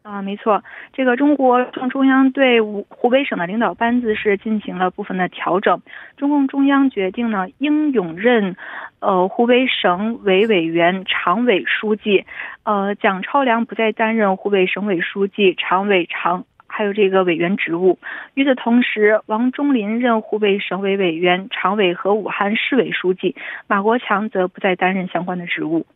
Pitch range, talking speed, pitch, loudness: 190-245 Hz, 255 characters per minute, 210 Hz, -17 LUFS